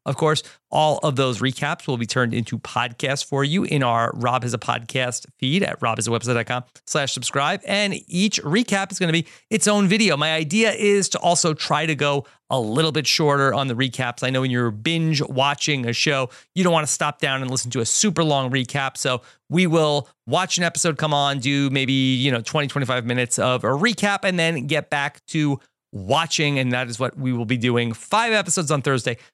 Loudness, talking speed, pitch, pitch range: -21 LUFS, 215 wpm, 140 Hz, 125-165 Hz